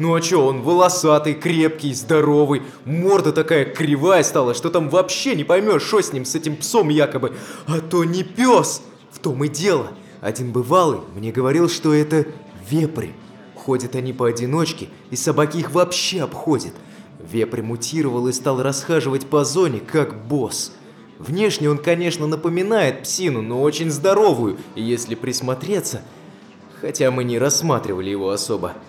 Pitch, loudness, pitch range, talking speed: 150 Hz, -19 LUFS, 130-170 Hz, 145 wpm